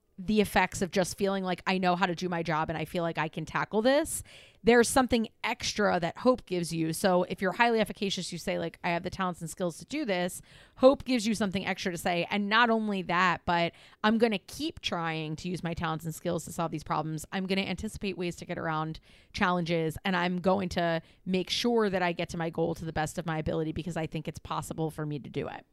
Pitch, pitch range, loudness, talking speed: 180 Hz, 165-195 Hz, -30 LUFS, 255 wpm